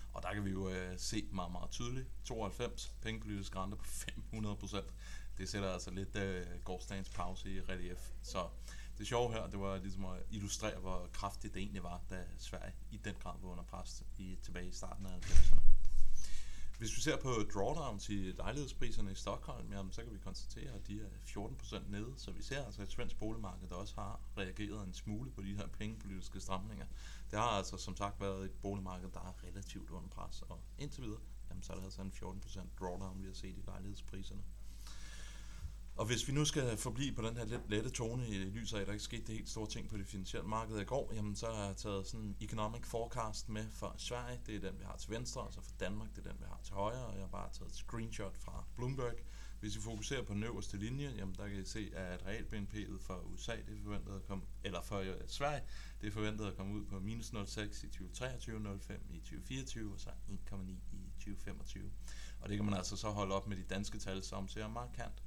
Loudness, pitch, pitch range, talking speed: -44 LUFS, 100 Hz, 95-110 Hz, 225 wpm